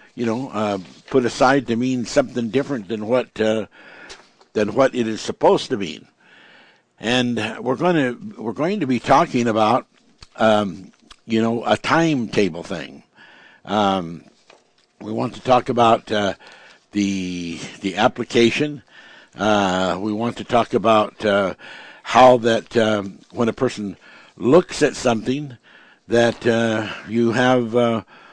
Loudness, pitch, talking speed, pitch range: -20 LUFS, 115 Hz, 140 wpm, 105-125 Hz